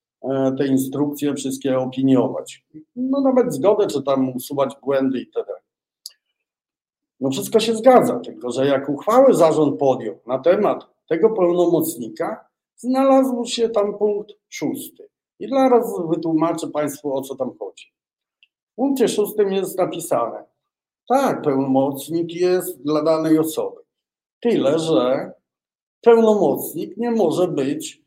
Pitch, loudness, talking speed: 175 Hz, -19 LUFS, 120 wpm